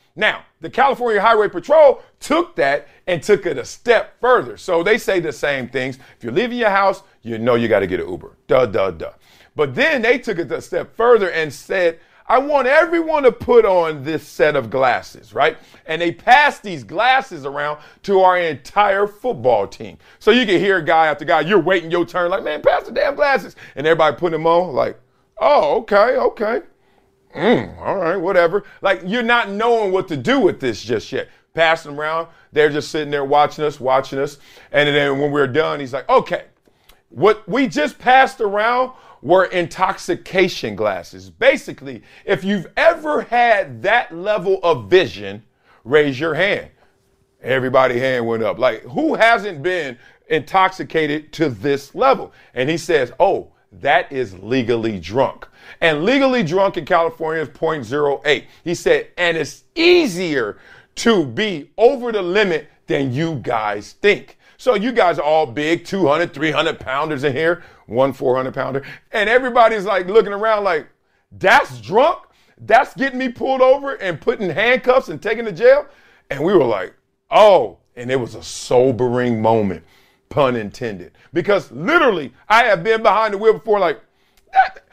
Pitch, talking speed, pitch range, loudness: 180 Hz, 170 wpm, 145-235 Hz, -17 LUFS